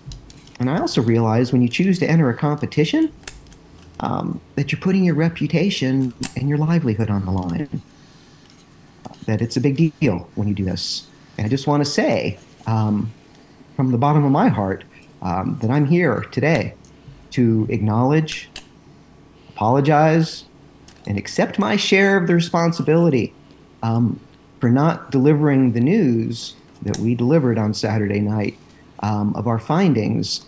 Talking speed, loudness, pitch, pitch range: 150 wpm, -19 LUFS, 130 Hz, 110-155 Hz